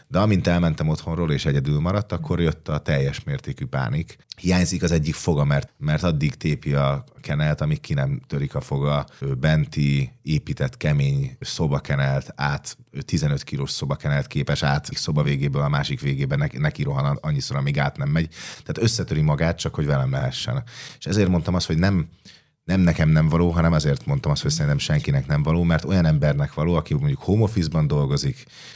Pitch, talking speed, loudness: 85 Hz, 175 wpm, -22 LUFS